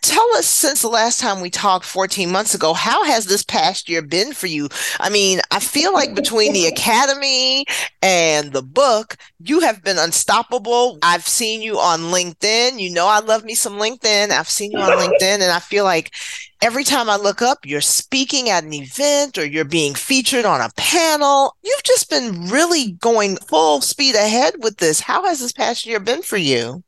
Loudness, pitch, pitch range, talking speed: -16 LUFS, 210 Hz, 180-260 Hz, 200 wpm